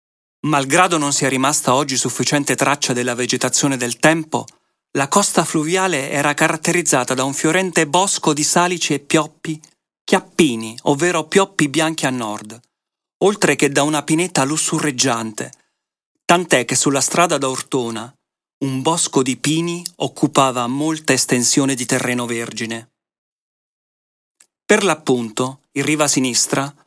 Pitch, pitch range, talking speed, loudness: 140 Hz, 130-160 Hz, 125 wpm, -17 LUFS